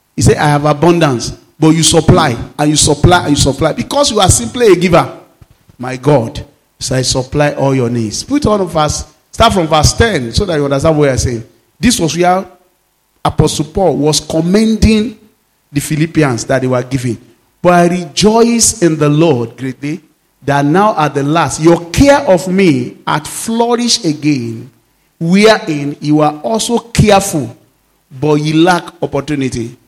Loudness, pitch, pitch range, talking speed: -11 LUFS, 150 Hz, 130-175 Hz, 170 wpm